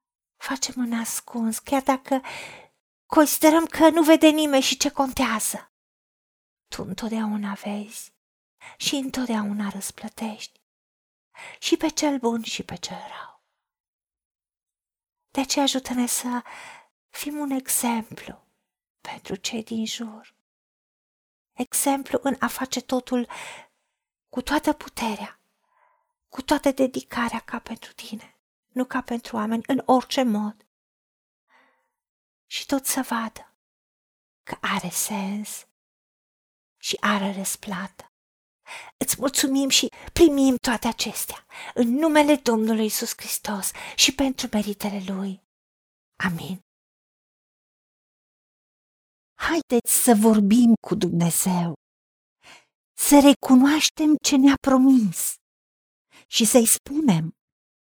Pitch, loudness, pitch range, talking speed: 245 Hz, -22 LUFS, 215-275 Hz, 100 wpm